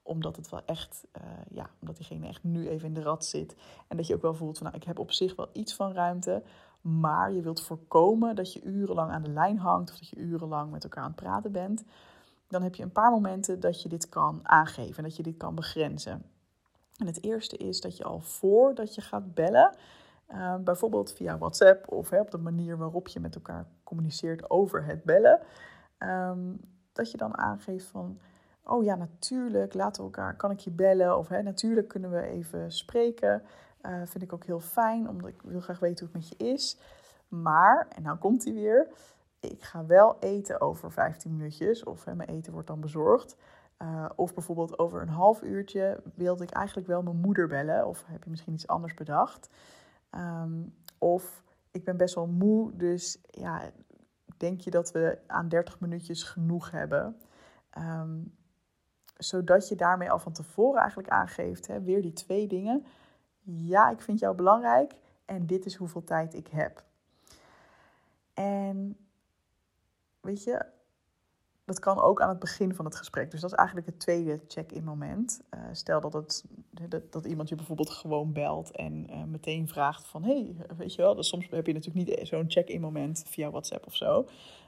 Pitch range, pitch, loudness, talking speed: 160-195 Hz, 175 Hz, -29 LUFS, 195 wpm